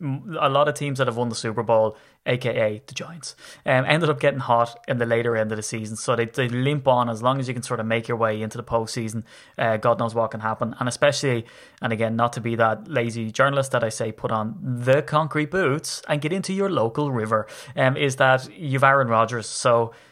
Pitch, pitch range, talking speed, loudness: 120 Hz, 115-140 Hz, 240 wpm, -23 LUFS